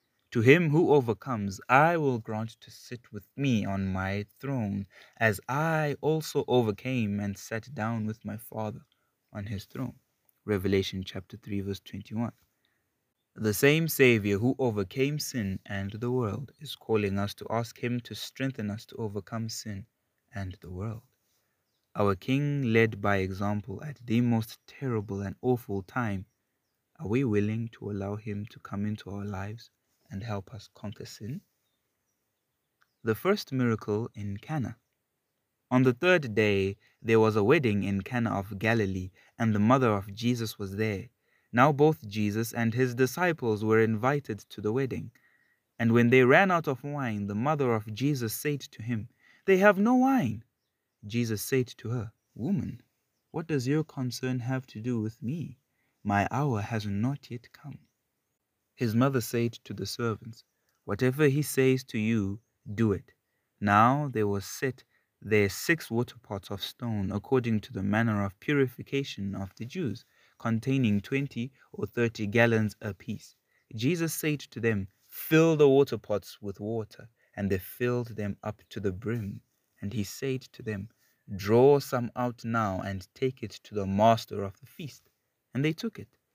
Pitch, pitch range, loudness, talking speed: 115 Hz, 105-130 Hz, -29 LUFS, 165 wpm